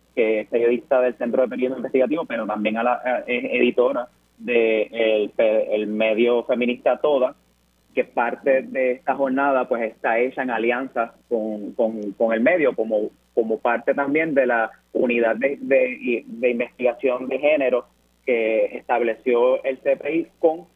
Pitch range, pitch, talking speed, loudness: 110-135 Hz, 125 Hz, 155 wpm, -21 LUFS